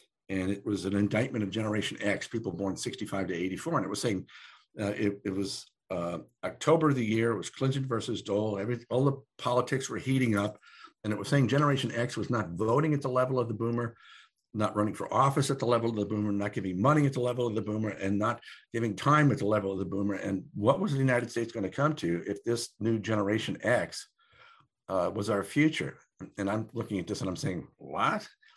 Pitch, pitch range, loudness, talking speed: 115 Hz, 100-130 Hz, -30 LUFS, 230 wpm